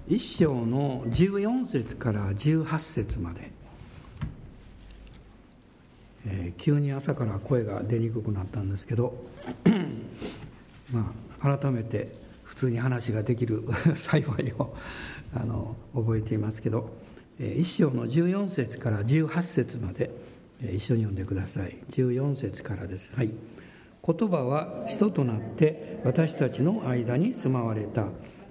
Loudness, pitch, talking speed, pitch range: -29 LUFS, 120 Hz, 220 characters per minute, 110-140 Hz